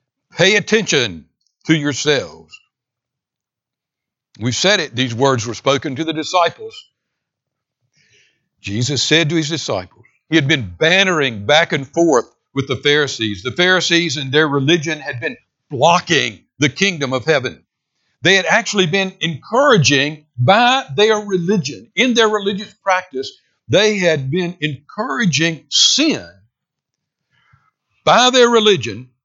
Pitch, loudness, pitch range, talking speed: 160 Hz, -15 LUFS, 135-195 Hz, 125 wpm